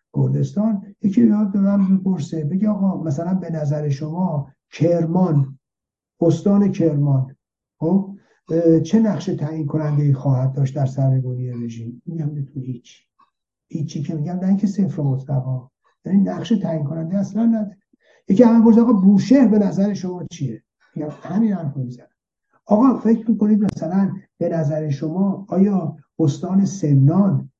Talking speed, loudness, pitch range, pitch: 145 wpm, -19 LUFS, 145-200 Hz, 170 Hz